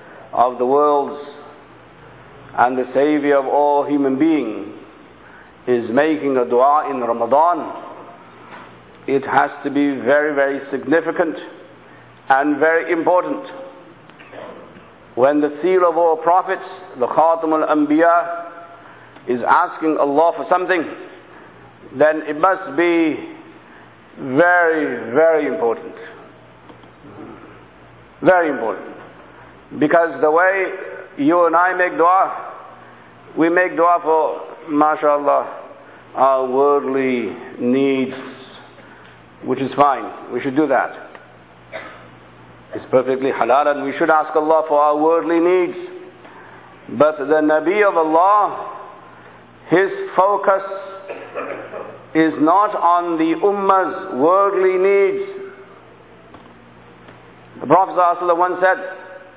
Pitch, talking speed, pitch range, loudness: 160 Hz, 105 wpm, 140-185 Hz, -17 LUFS